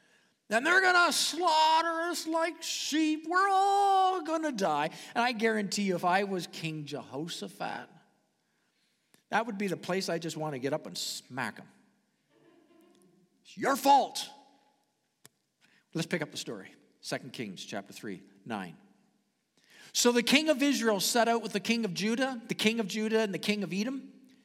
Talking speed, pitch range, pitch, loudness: 170 wpm, 190-310 Hz, 230 Hz, -29 LUFS